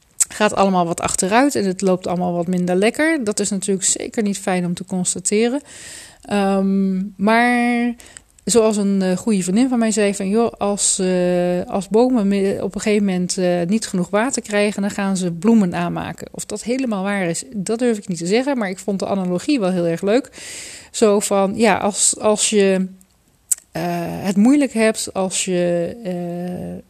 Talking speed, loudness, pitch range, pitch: 180 wpm, -18 LUFS, 180-220 Hz, 200 Hz